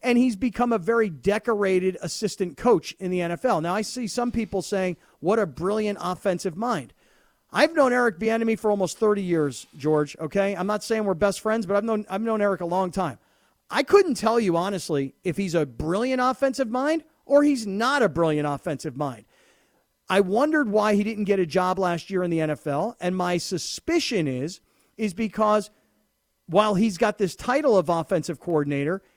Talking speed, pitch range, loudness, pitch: 190 wpm, 175-225 Hz, -24 LUFS, 200 Hz